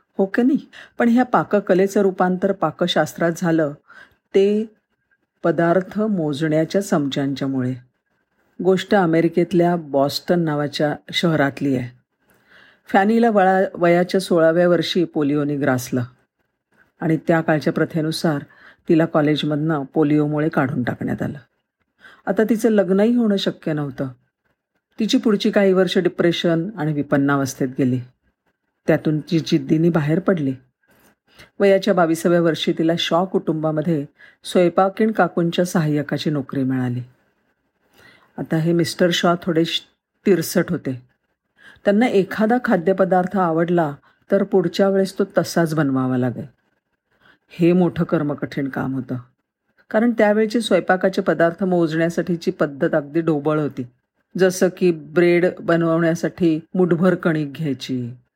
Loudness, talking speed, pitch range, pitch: -19 LUFS, 110 wpm, 150-190 Hz, 170 Hz